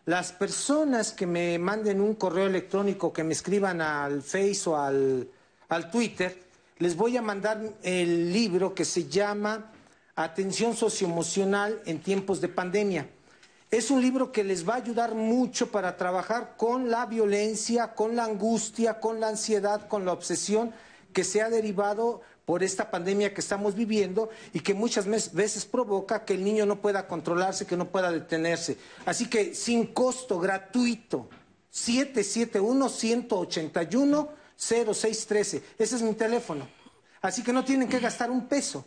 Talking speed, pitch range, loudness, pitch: 165 wpm, 185-230 Hz, -28 LUFS, 205 Hz